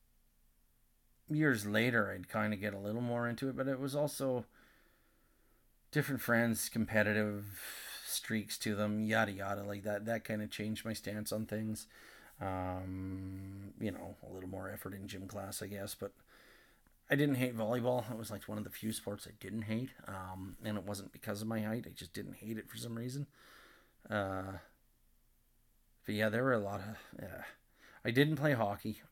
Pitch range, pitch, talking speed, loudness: 100-115 Hz, 105 Hz, 190 wpm, -38 LUFS